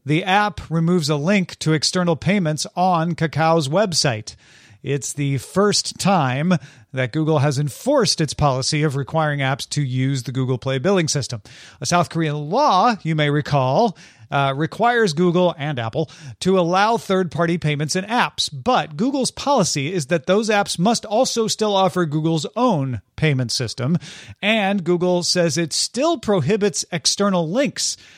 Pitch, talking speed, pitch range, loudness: 165 Hz, 155 wpm, 145-195 Hz, -19 LUFS